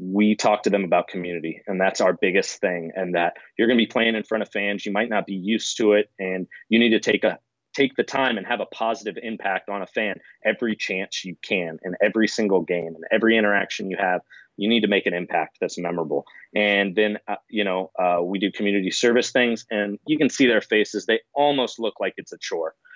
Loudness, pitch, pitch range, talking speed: -23 LUFS, 105 Hz, 95-115 Hz, 240 wpm